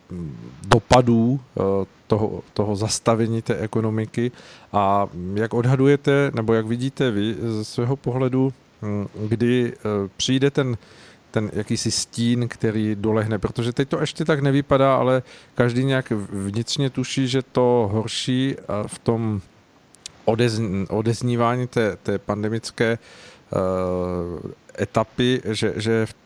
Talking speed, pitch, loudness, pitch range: 110 wpm, 115 Hz, -22 LUFS, 105-125 Hz